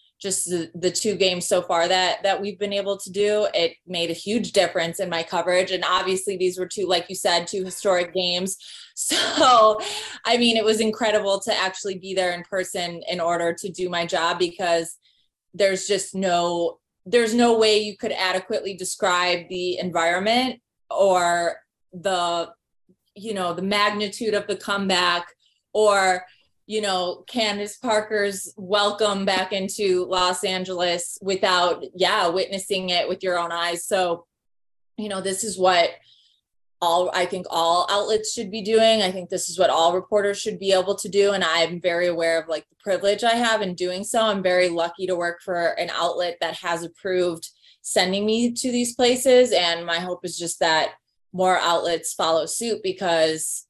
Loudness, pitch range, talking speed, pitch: -22 LUFS, 175-205 Hz, 175 wpm, 185 Hz